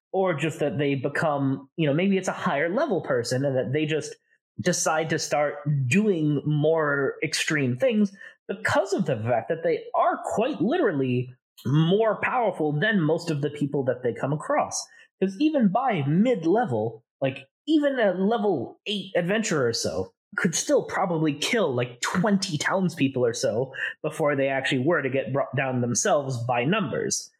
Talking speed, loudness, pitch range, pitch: 170 wpm, -25 LUFS, 135-195 Hz, 155 Hz